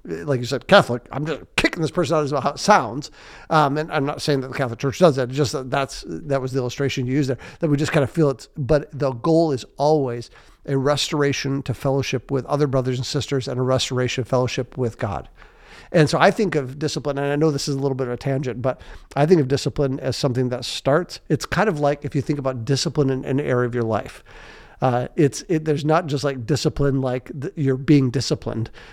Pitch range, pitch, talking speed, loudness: 130-150 Hz, 140 Hz, 245 wpm, -21 LUFS